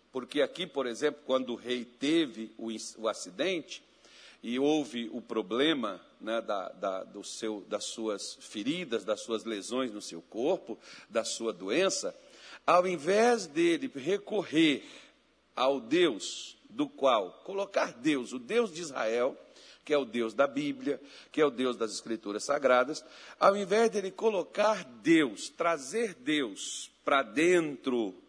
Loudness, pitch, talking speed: -31 LUFS, 155 Hz, 140 wpm